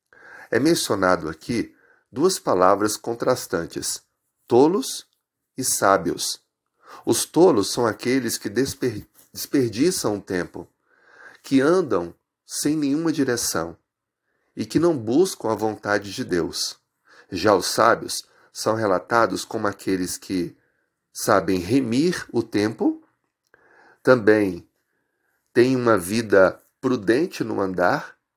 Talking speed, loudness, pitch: 105 wpm, -22 LUFS, 115 Hz